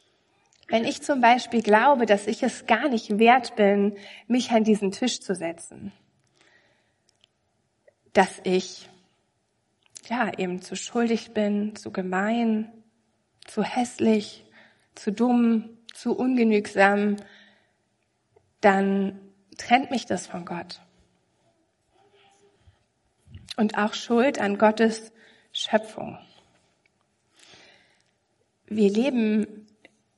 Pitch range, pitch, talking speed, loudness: 195-235 Hz, 215 Hz, 95 wpm, -24 LUFS